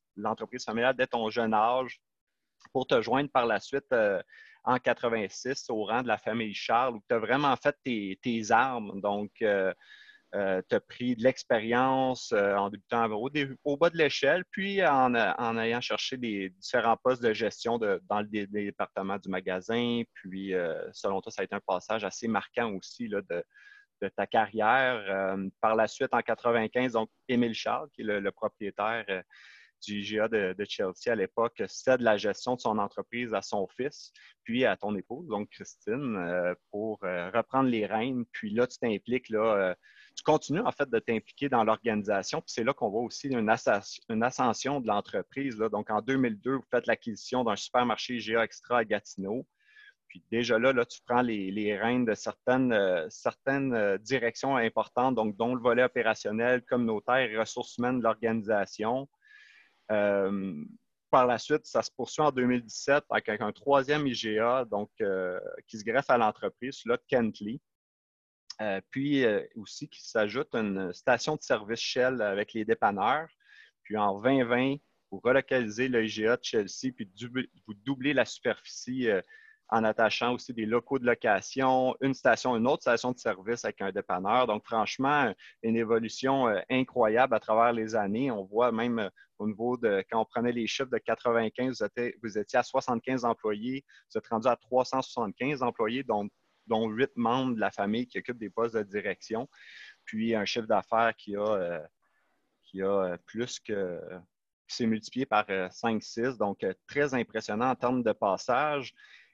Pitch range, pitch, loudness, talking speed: 110-130 Hz, 120 Hz, -29 LUFS, 180 wpm